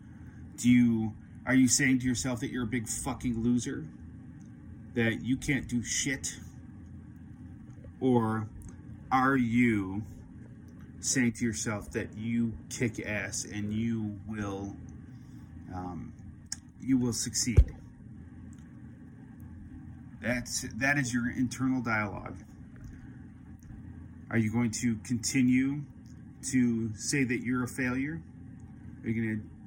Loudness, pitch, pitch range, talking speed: -30 LUFS, 115 Hz, 105-125 Hz, 115 wpm